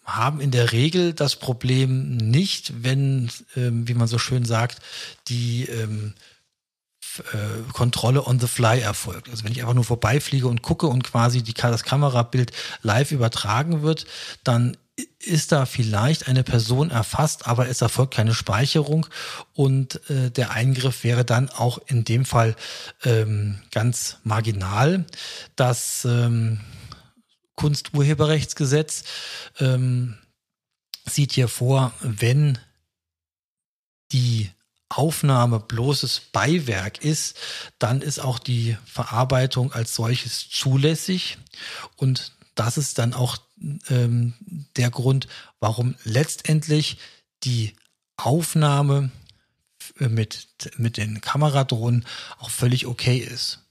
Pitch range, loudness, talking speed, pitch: 115-140 Hz, -22 LUFS, 120 wpm, 125 Hz